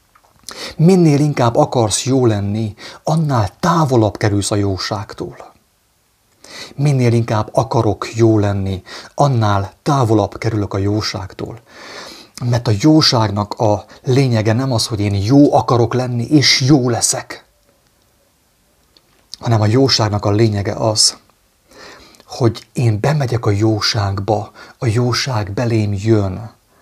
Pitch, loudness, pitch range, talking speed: 115 Hz, -15 LUFS, 105-125 Hz, 110 wpm